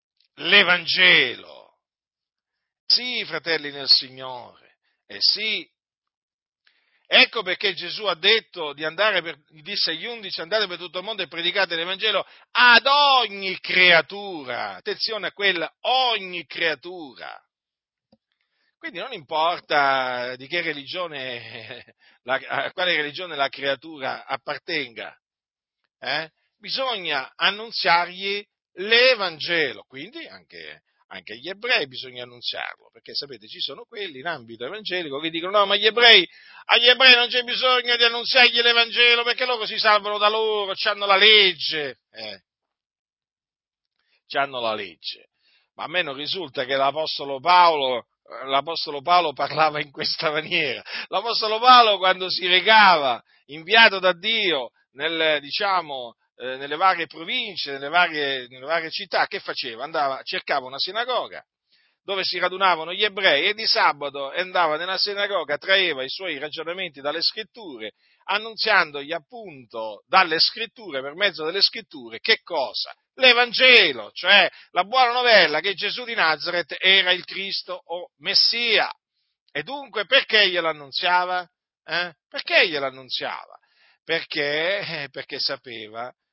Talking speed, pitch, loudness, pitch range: 125 wpm, 185 Hz, -20 LUFS, 155-225 Hz